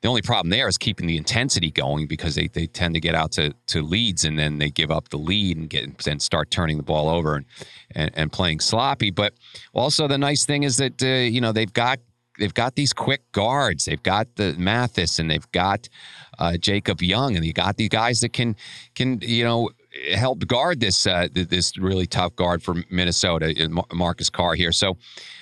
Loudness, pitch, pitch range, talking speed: -22 LUFS, 95 Hz, 85-115 Hz, 210 wpm